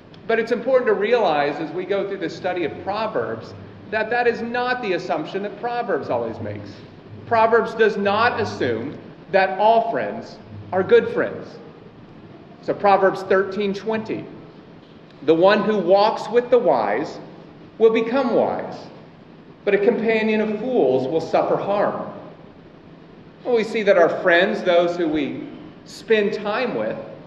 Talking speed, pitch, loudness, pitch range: 145 wpm, 210 Hz, -20 LUFS, 185-230 Hz